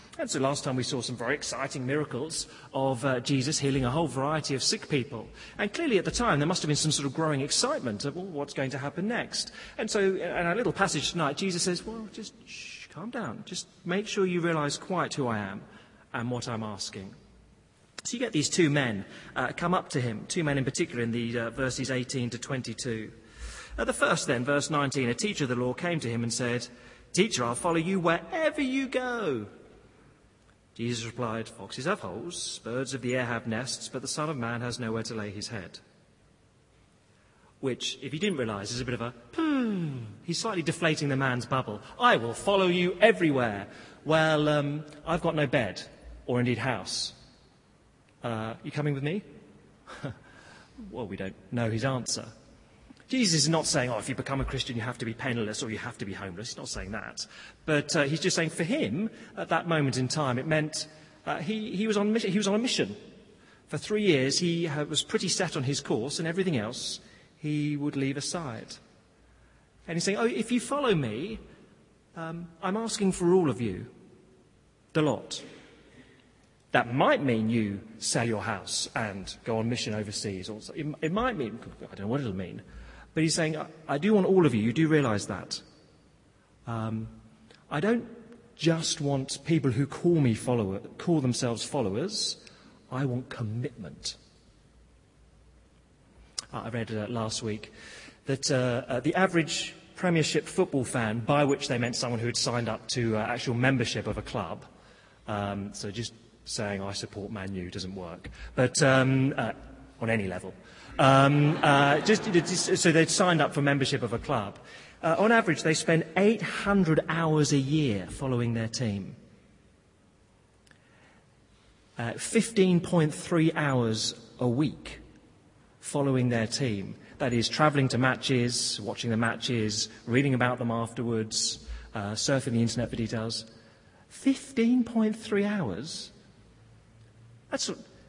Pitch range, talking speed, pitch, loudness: 115-165 Hz, 180 wpm, 135 Hz, -29 LUFS